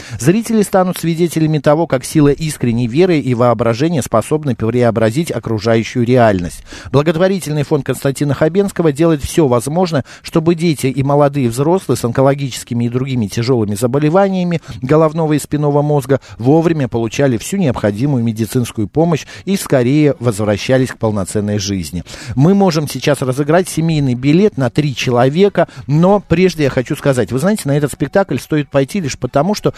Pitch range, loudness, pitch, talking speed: 120-160 Hz, -14 LUFS, 140 Hz, 145 wpm